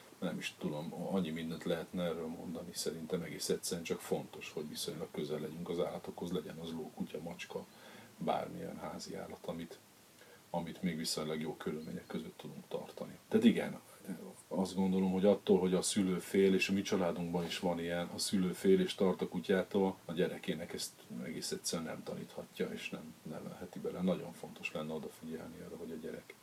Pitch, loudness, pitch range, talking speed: 90 Hz, -37 LUFS, 80-95 Hz, 175 wpm